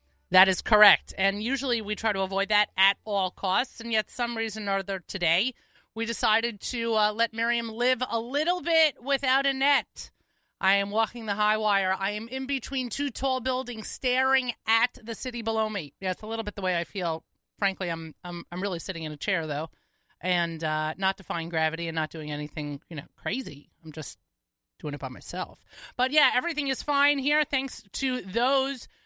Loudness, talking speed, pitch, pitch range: -27 LUFS, 200 wpm, 215 Hz, 180-255 Hz